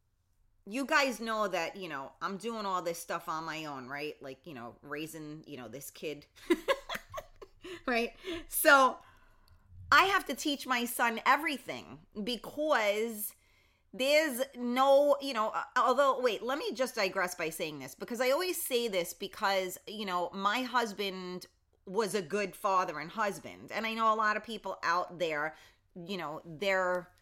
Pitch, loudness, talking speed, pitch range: 205 Hz, -32 LUFS, 165 wpm, 160-255 Hz